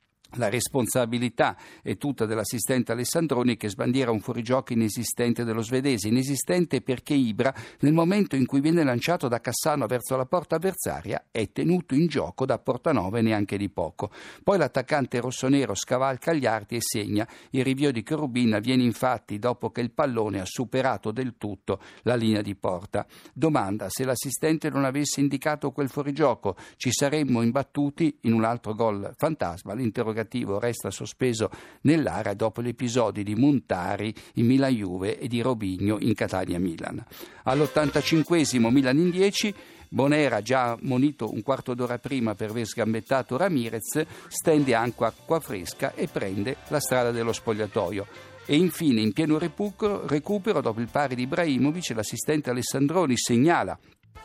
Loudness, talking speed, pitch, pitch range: -26 LUFS, 145 wpm, 125 Hz, 115-145 Hz